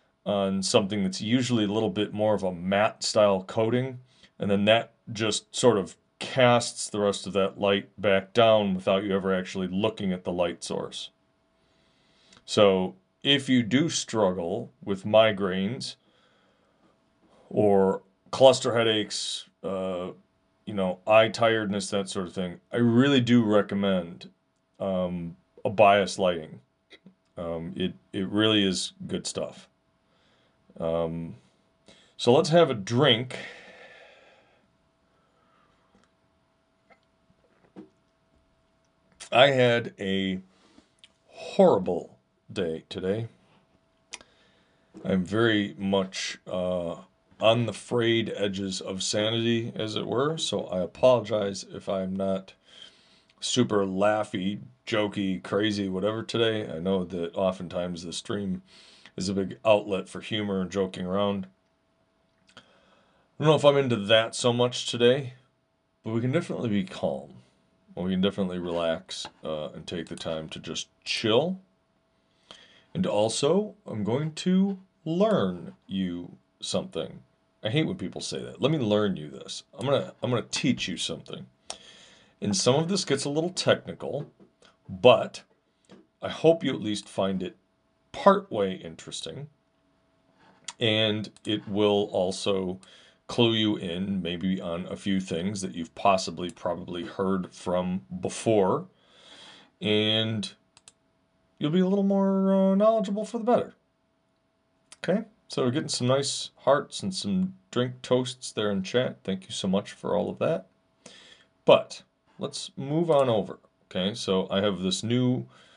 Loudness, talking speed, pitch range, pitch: -26 LUFS, 135 wpm, 95-120 Hz, 100 Hz